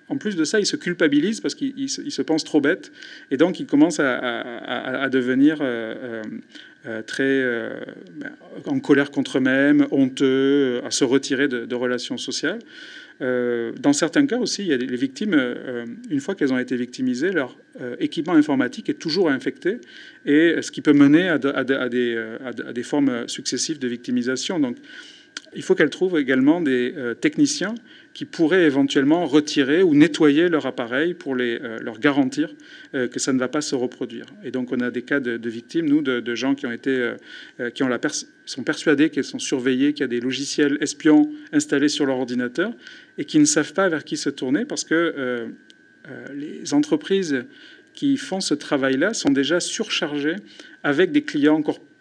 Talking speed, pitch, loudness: 195 wpm, 145 Hz, -21 LUFS